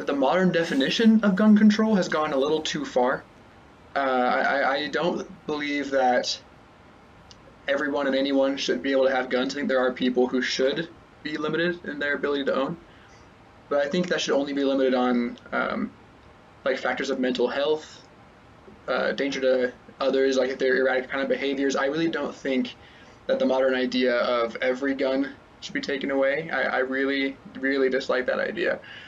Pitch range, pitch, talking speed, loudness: 125-145 Hz, 135 Hz, 185 wpm, -24 LUFS